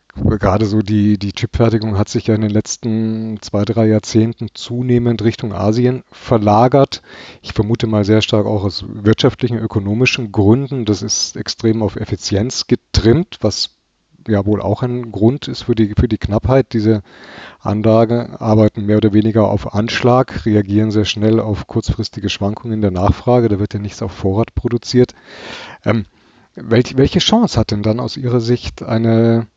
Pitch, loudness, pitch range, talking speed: 110 Hz, -15 LUFS, 105-120 Hz, 165 wpm